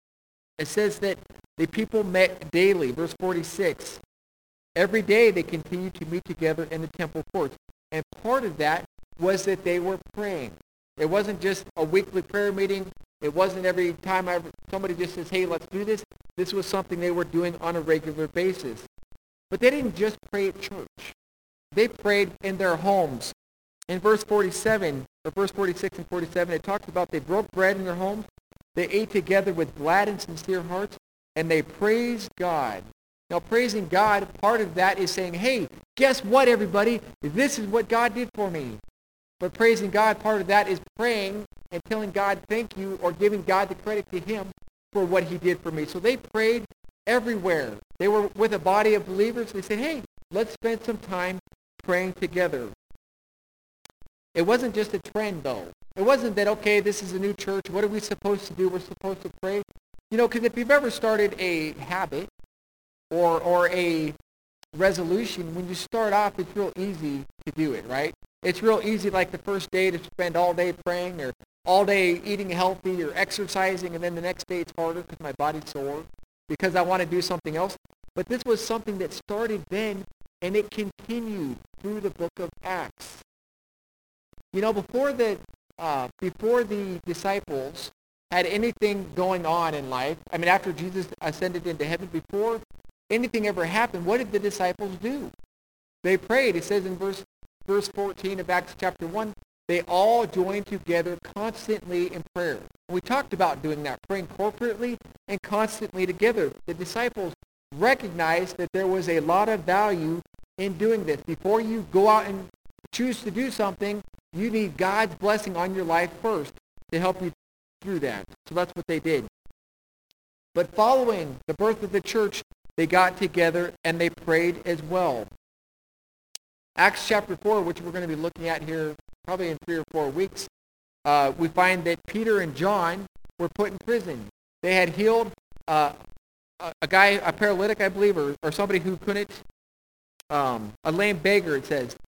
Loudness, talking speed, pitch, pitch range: -26 LUFS, 180 wpm, 185 Hz, 170-210 Hz